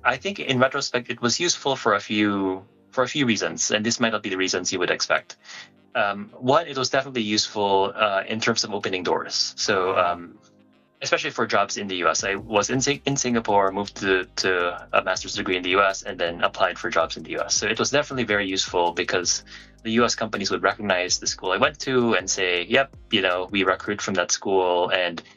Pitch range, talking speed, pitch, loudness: 95-125 Hz, 220 wpm, 105 Hz, -23 LUFS